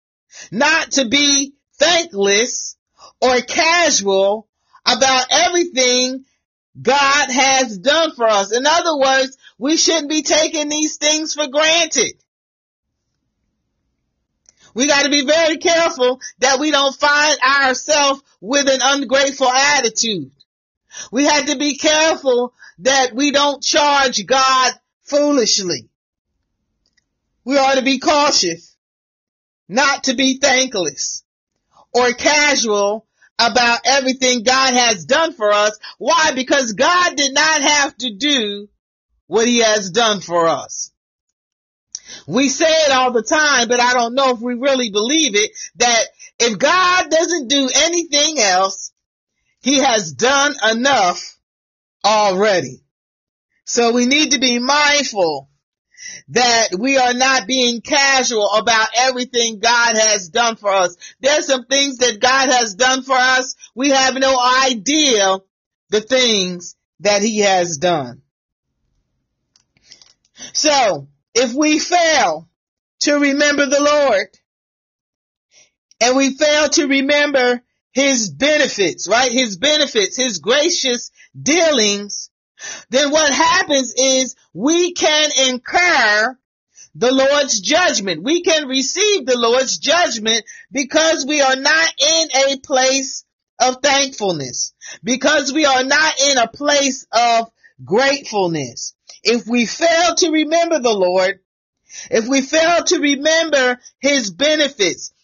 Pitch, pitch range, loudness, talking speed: 270 Hz, 235-295 Hz, -15 LUFS, 125 wpm